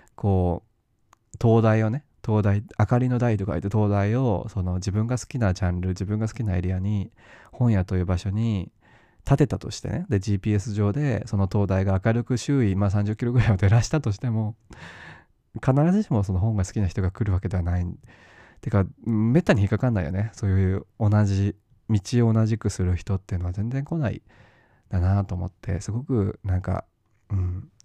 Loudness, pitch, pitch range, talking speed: -24 LUFS, 105 Hz, 95-115 Hz, 355 characters per minute